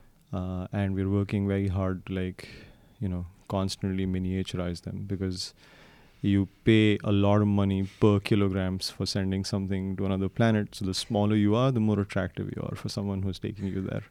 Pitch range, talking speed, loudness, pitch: 95-105 Hz, 185 wpm, -28 LUFS, 100 Hz